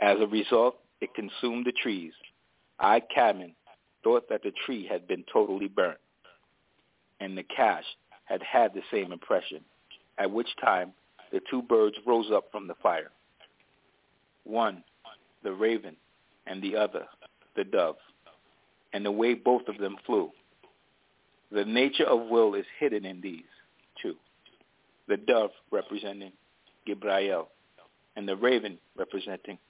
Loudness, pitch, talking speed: -29 LUFS, 115 Hz, 135 wpm